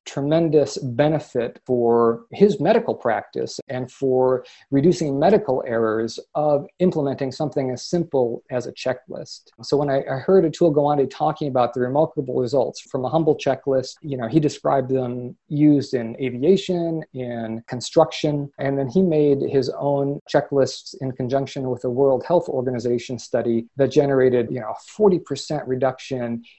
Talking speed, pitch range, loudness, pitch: 150 wpm, 125-150 Hz, -21 LUFS, 135 Hz